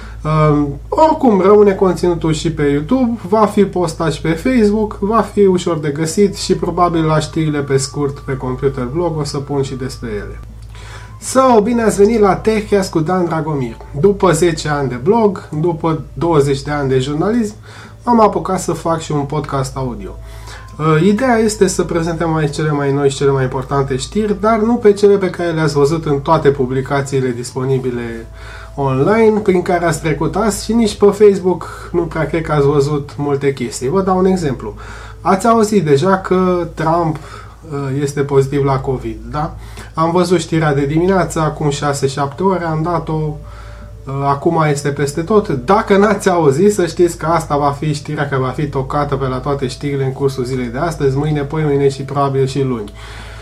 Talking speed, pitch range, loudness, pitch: 185 wpm, 135-185 Hz, -15 LUFS, 150 Hz